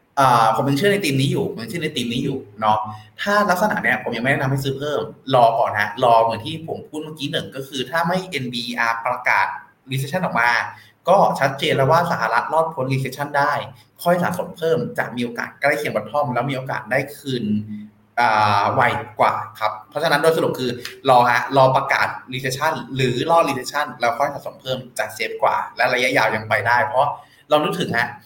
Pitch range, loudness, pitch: 120-155 Hz, -20 LUFS, 135 Hz